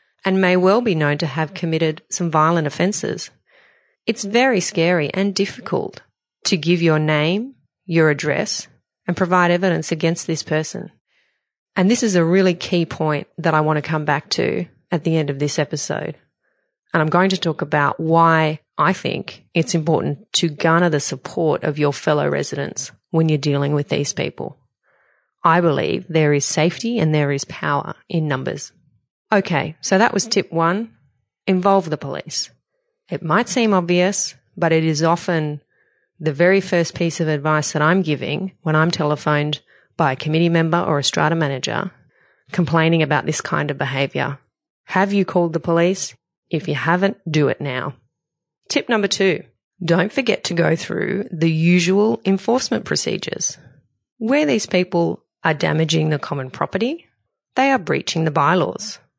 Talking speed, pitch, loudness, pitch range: 165 wpm, 165 Hz, -19 LUFS, 155-190 Hz